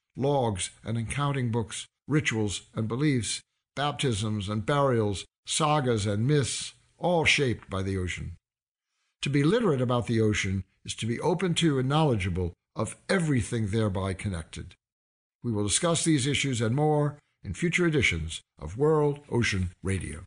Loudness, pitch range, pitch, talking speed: -27 LUFS, 100-145 Hz, 115 Hz, 145 wpm